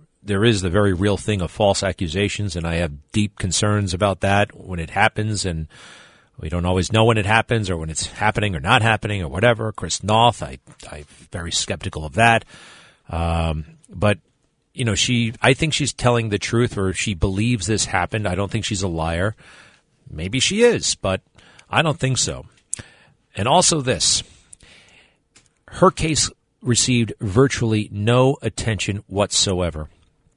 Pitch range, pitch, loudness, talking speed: 90-115 Hz, 105 Hz, -20 LUFS, 165 wpm